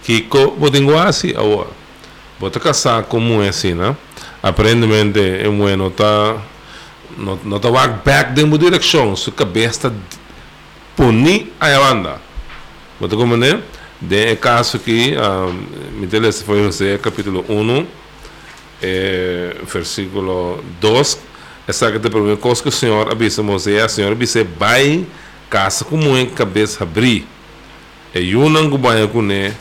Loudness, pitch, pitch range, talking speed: -14 LUFS, 110 Hz, 100-125 Hz, 90 wpm